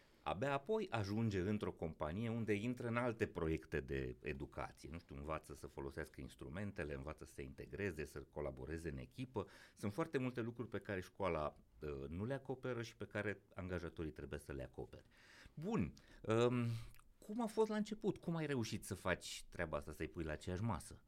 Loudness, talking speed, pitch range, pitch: -44 LUFS, 180 wpm, 75-120 Hz, 100 Hz